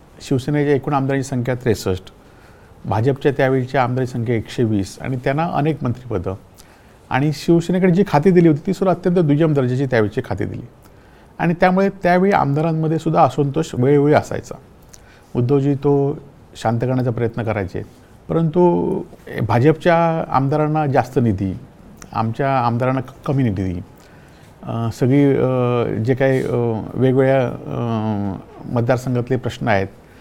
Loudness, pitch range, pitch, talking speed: -18 LUFS, 115-150 Hz, 130 Hz, 115 wpm